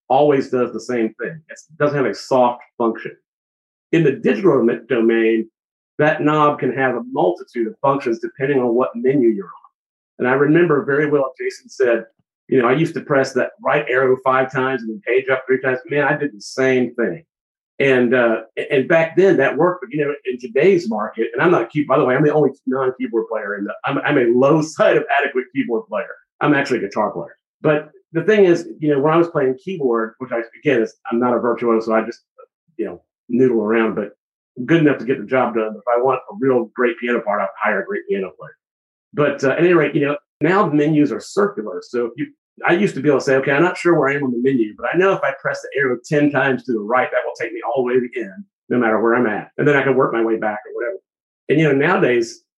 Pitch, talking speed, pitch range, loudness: 130 Hz, 255 wpm, 120-150 Hz, -18 LUFS